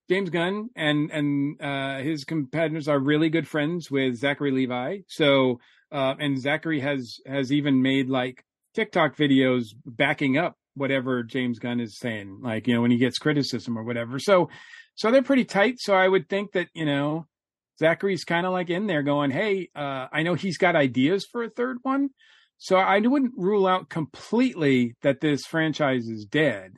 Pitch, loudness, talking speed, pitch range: 150 Hz, -24 LUFS, 185 wpm, 135-185 Hz